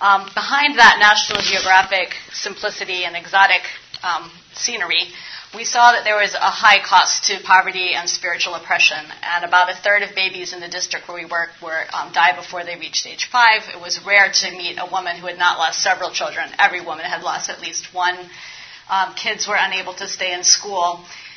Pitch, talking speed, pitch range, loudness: 185 Hz, 195 wpm, 175-200 Hz, -16 LUFS